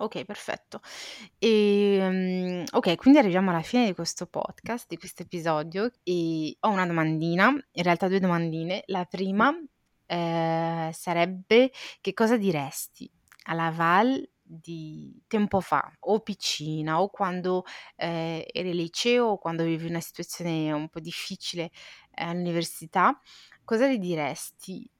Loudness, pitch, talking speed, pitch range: -26 LUFS, 180 Hz, 130 wpm, 165-205 Hz